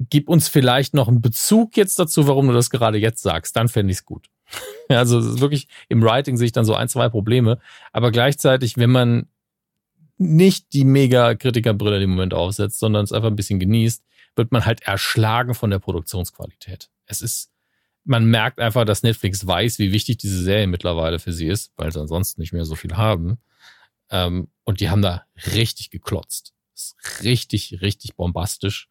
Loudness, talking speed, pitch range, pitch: -19 LUFS, 185 wpm, 100-125 Hz, 115 Hz